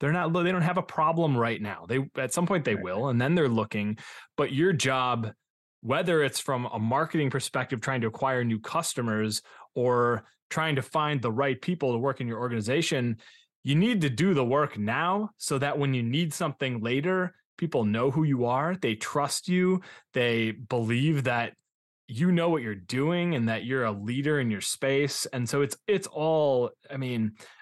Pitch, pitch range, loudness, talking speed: 135 Hz, 120-160 Hz, -27 LUFS, 195 wpm